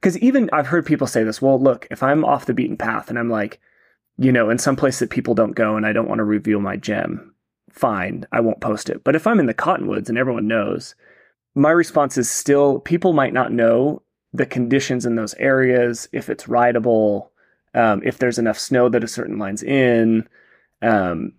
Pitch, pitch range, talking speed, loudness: 120 Hz, 115-135 Hz, 215 wpm, -19 LUFS